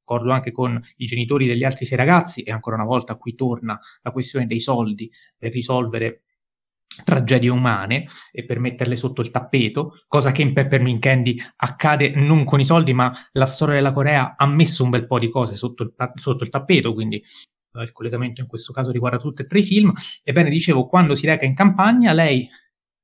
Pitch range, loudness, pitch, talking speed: 120-145 Hz, -19 LUFS, 130 Hz, 195 wpm